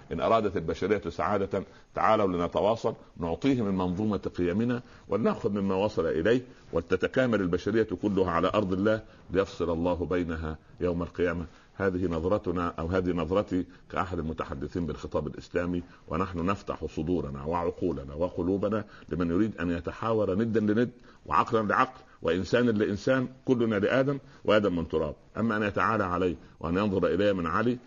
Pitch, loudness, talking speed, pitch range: 95 Hz, -29 LUFS, 135 wpm, 85-110 Hz